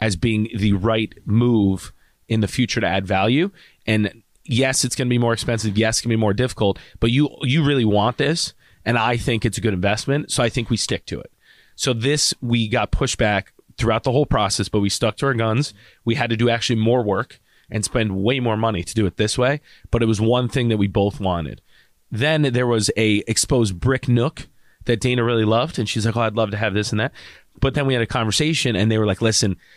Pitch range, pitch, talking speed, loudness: 105-125 Hz, 115 Hz, 245 wpm, -20 LUFS